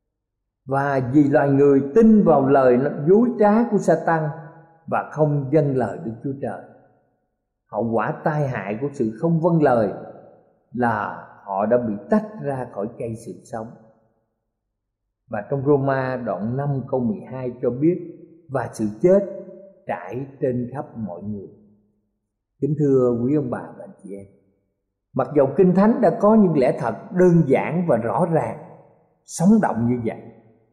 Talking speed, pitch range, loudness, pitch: 155 wpm, 115-165 Hz, -20 LUFS, 135 Hz